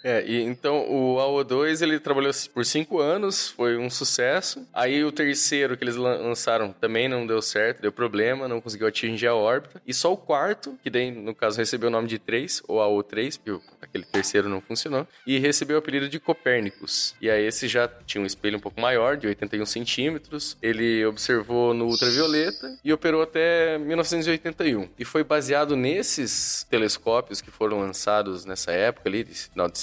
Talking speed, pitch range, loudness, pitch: 185 wpm, 110-150 Hz, -24 LUFS, 125 Hz